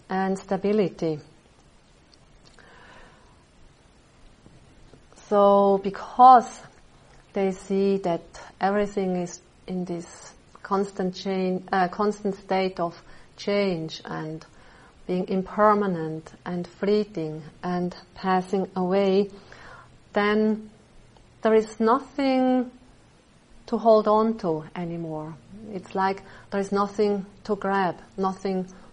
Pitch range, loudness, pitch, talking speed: 180-205 Hz, -24 LUFS, 195 Hz, 90 wpm